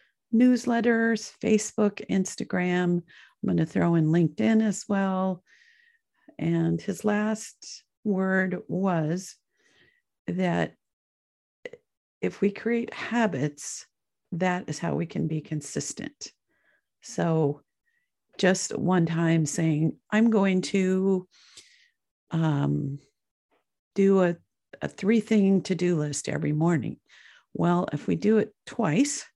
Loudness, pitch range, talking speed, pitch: -26 LUFS, 170-220 Hz, 110 wpm, 190 Hz